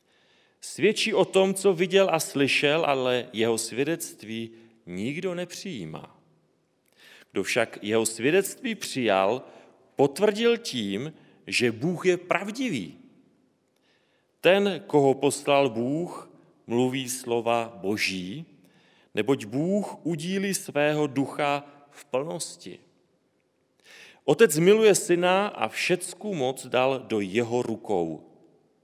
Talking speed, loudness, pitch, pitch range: 100 wpm, -25 LUFS, 145 Hz, 120-195 Hz